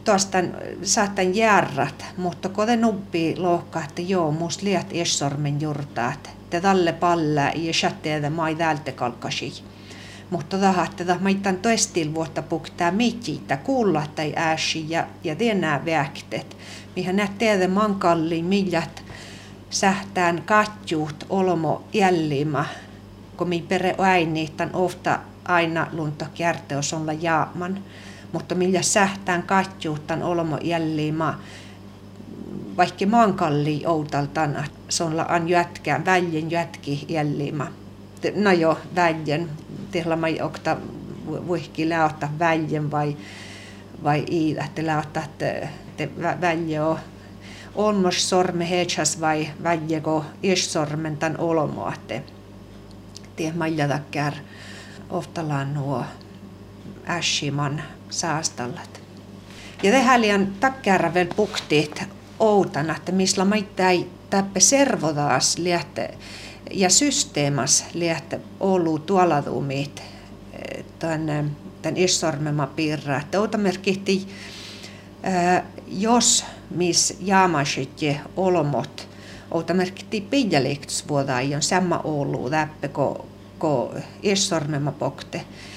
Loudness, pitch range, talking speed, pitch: -22 LUFS, 145-180 Hz, 95 wpm, 160 Hz